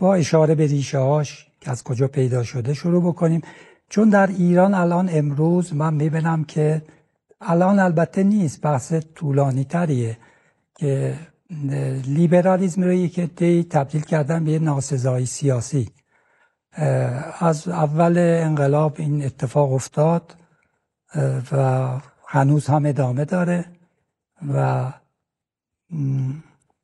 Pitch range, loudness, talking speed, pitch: 140-170 Hz, -20 LUFS, 105 wpm, 155 Hz